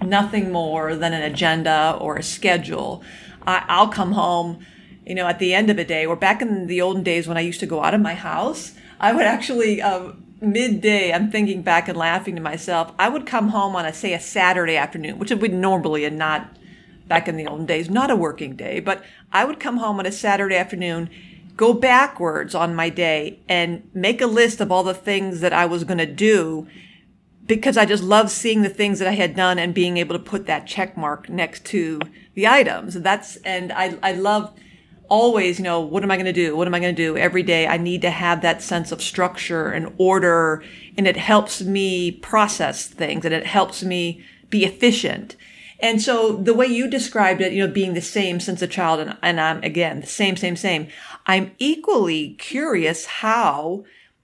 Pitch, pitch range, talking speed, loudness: 185 Hz, 170-210 Hz, 215 wpm, -20 LUFS